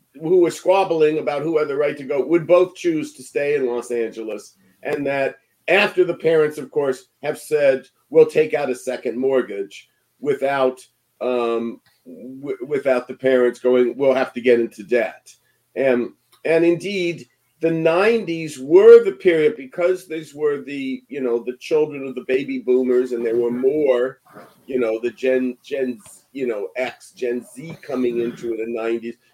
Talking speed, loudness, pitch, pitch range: 175 wpm, -20 LUFS, 135 Hz, 125-180 Hz